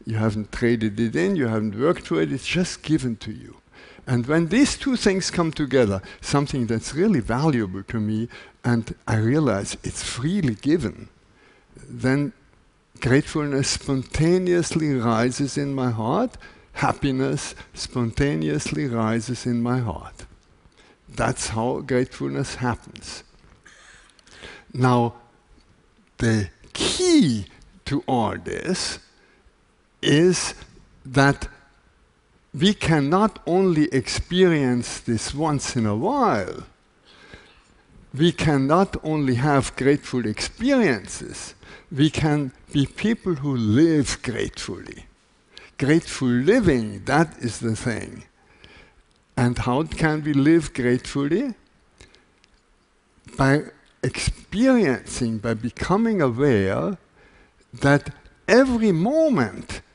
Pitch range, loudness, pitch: 115-155 Hz, -22 LUFS, 130 Hz